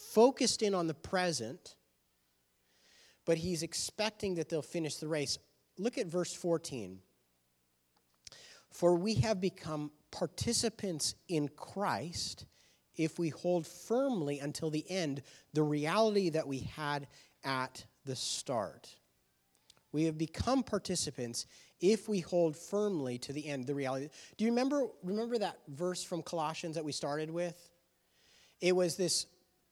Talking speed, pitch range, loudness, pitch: 135 wpm, 140-180 Hz, -35 LUFS, 160 Hz